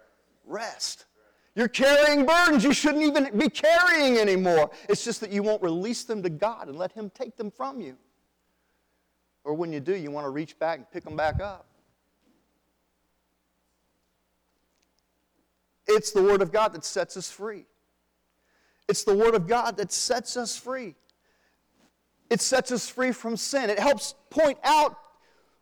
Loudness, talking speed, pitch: -25 LUFS, 160 wpm, 205 Hz